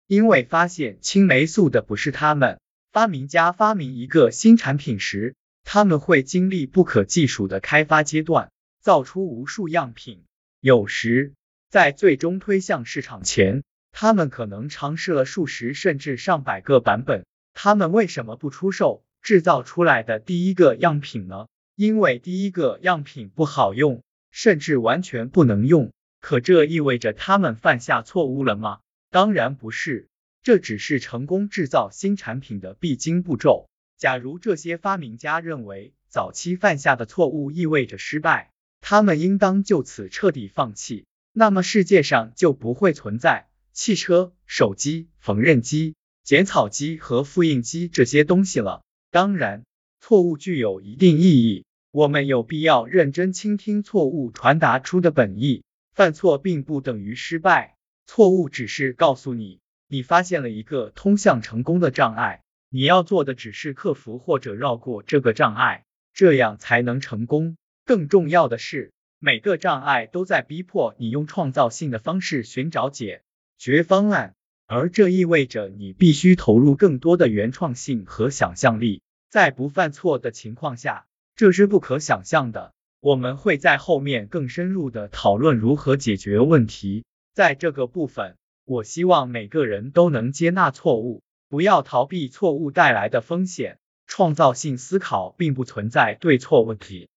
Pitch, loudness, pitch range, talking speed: 150 Hz, -20 LUFS, 125-180 Hz, 245 characters per minute